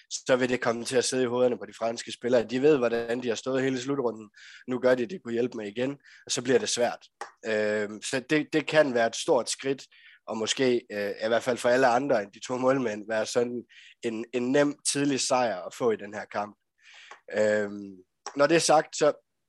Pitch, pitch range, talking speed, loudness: 125 Hz, 110-130 Hz, 225 wpm, -27 LUFS